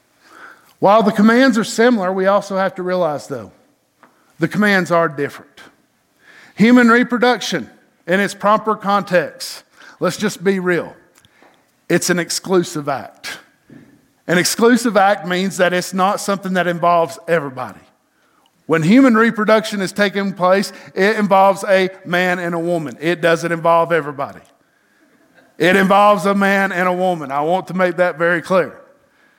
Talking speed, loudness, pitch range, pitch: 145 wpm, -15 LUFS, 170-200 Hz, 185 Hz